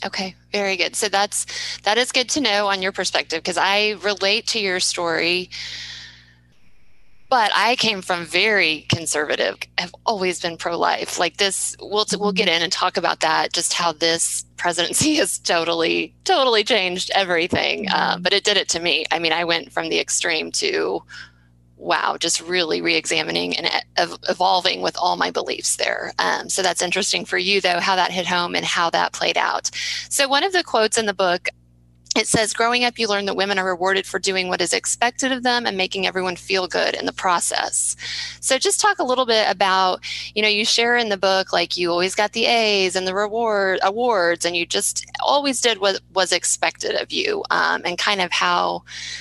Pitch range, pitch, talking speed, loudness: 170-220 Hz, 190 Hz, 200 wpm, -19 LUFS